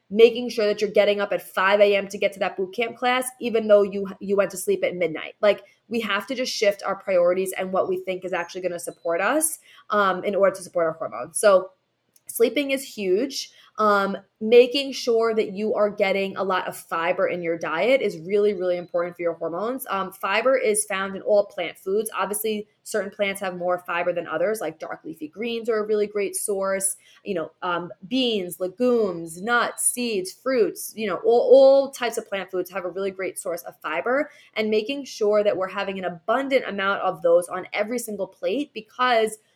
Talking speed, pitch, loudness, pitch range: 210 wpm, 205 Hz, -23 LUFS, 185-230 Hz